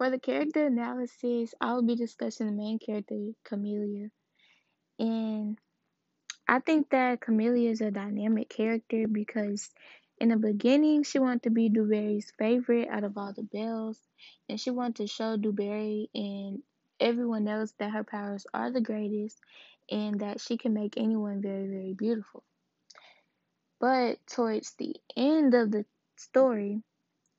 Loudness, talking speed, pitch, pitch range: -30 LUFS, 145 wpm, 220 Hz, 210-240 Hz